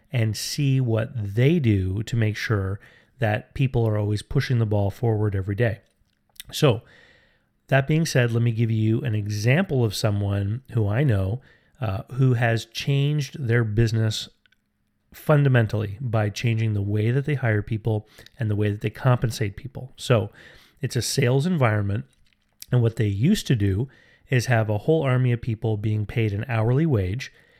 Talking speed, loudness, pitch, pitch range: 170 wpm, -23 LUFS, 115 Hz, 105-130 Hz